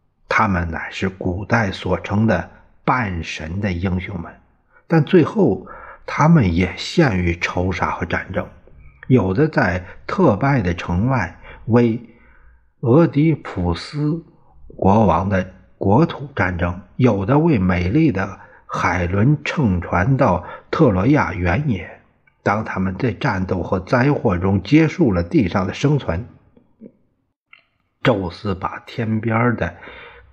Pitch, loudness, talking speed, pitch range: 100 Hz, -19 LUFS, 175 characters per minute, 90-135 Hz